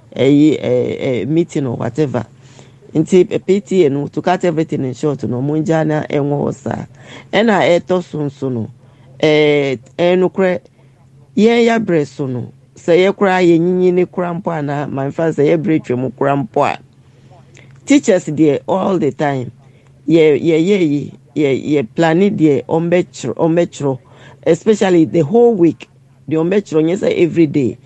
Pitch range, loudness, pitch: 135-175 Hz, -15 LUFS, 150 Hz